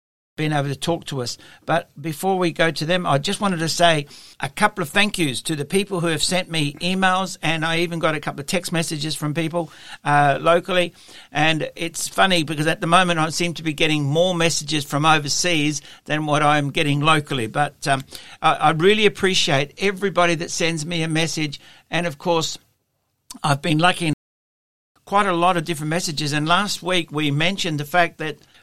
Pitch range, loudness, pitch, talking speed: 150-175 Hz, -20 LUFS, 165 Hz, 205 wpm